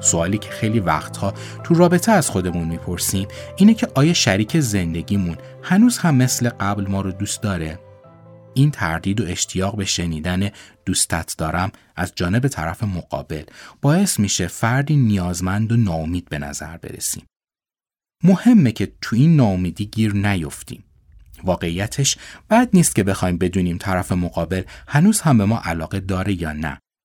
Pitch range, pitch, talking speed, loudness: 90-125 Hz, 100 Hz, 145 wpm, -19 LUFS